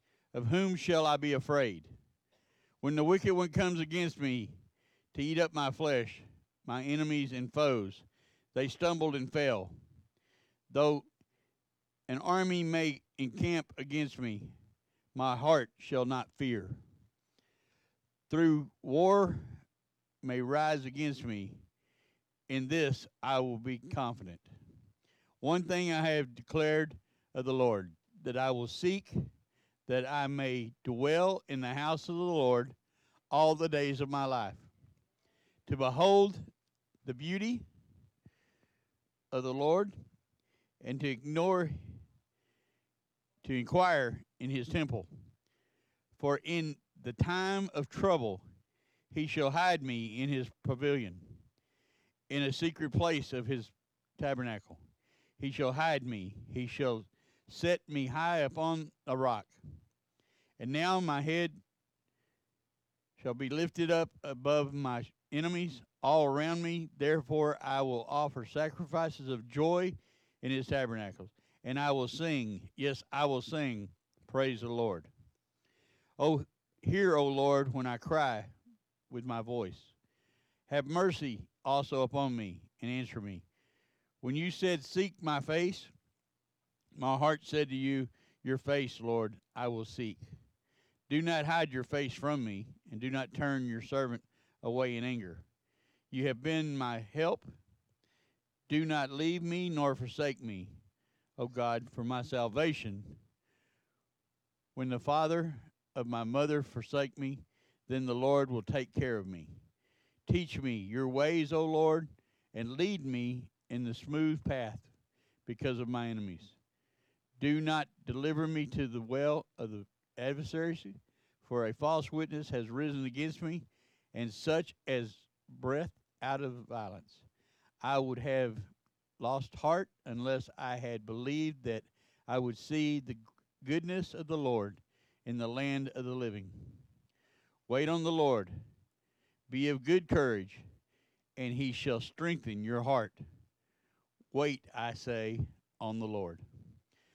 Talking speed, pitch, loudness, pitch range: 135 wpm, 130 Hz, -35 LUFS, 120-150 Hz